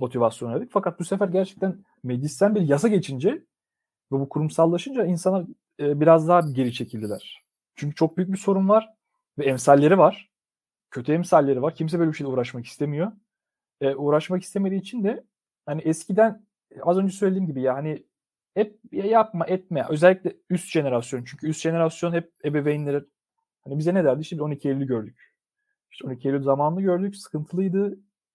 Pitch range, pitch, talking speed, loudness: 145-195 Hz, 165 Hz, 155 wpm, -23 LUFS